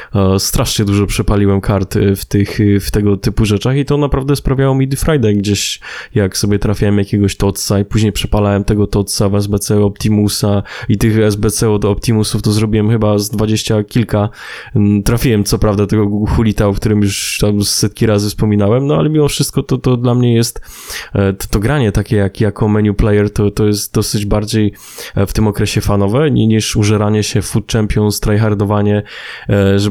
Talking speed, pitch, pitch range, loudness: 175 wpm, 105 Hz, 100-110 Hz, -13 LUFS